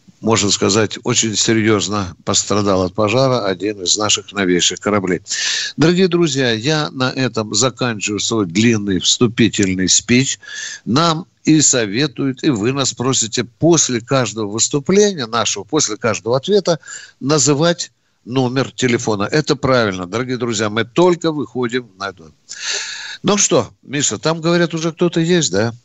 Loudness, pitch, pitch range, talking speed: -16 LUFS, 125 Hz, 105-155 Hz, 130 wpm